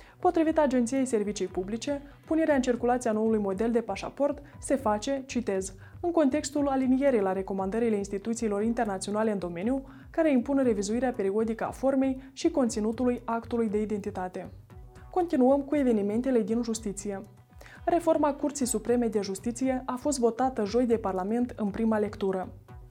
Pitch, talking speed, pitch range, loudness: 235 Hz, 140 wpm, 210-270 Hz, -28 LUFS